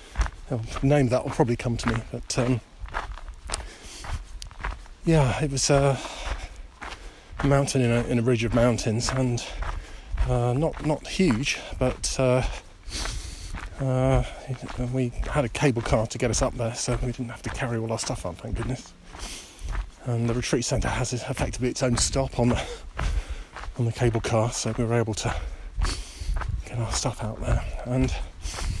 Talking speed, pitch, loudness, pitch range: 160 wpm, 120 Hz, -26 LUFS, 110-130 Hz